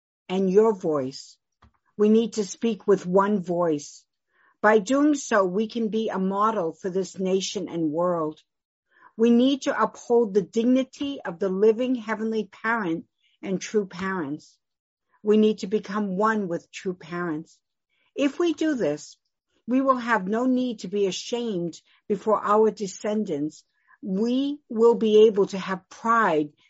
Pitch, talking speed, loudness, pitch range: 210 Hz, 150 wpm, -24 LUFS, 185-230 Hz